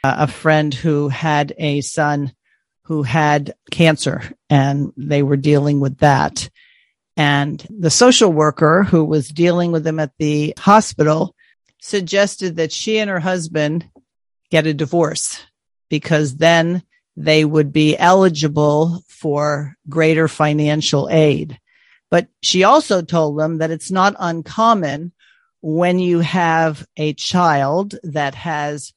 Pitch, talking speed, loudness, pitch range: 155 Hz, 130 wpm, -16 LUFS, 150-175 Hz